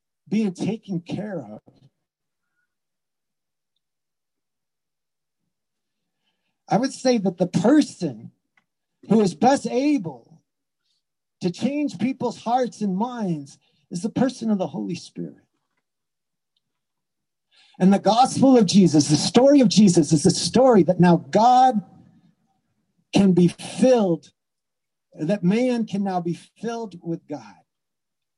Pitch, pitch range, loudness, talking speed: 200 Hz, 175-240 Hz, -20 LUFS, 110 wpm